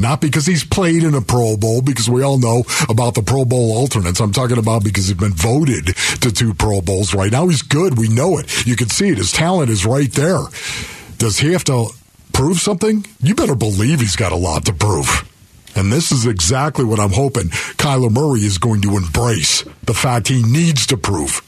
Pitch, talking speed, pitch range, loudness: 120 Hz, 220 wpm, 105-140 Hz, -15 LUFS